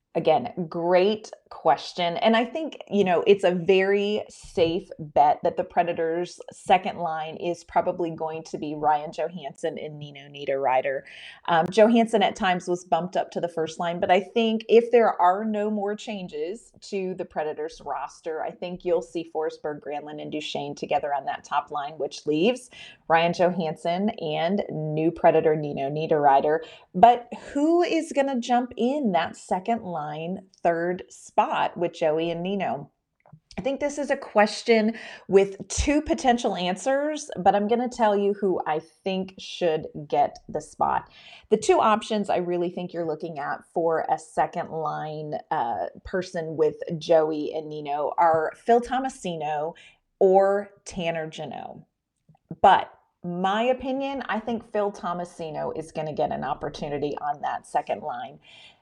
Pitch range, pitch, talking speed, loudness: 160-215 Hz, 175 Hz, 160 wpm, -25 LUFS